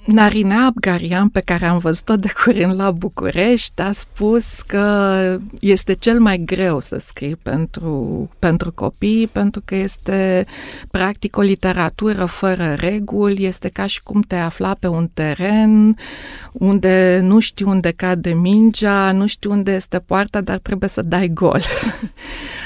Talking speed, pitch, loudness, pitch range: 145 wpm, 195 Hz, -17 LUFS, 180-210 Hz